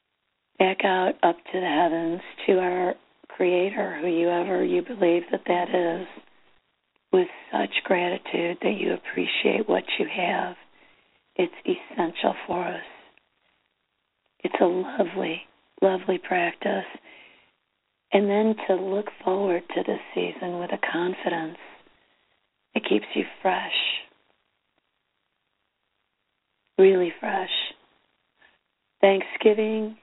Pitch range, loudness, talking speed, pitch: 175-215 Hz, -25 LUFS, 100 wpm, 185 Hz